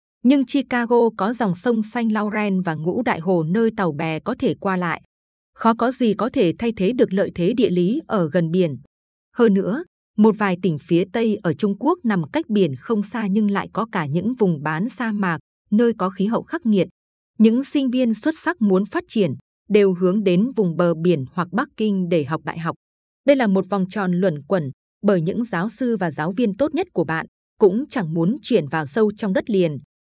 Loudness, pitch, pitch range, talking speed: -20 LUFS, 205 Hz, 180-235 Hz, 220 wpm